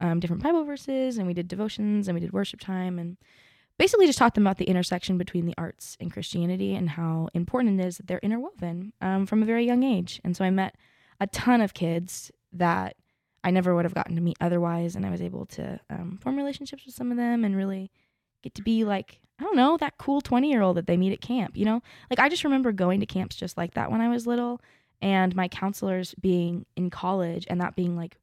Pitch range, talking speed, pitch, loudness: 175-235 Hz, 240 wpm, 190 Hz, -26 LUFS